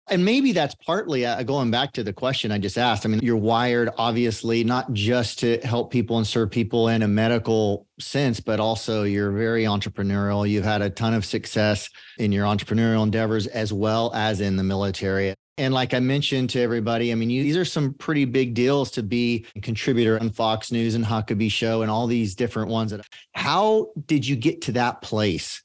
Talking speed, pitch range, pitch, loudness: 205 wpm, 110-125 Hz, 115 Hz, -23 LUFS